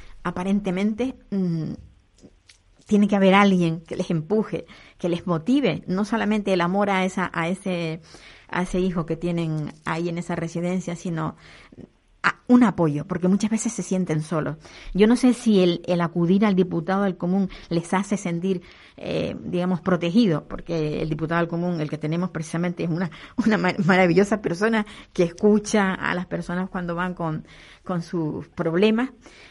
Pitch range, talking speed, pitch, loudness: 170-200 Hz, 165 wpm, 180 Hz, -23 LUFS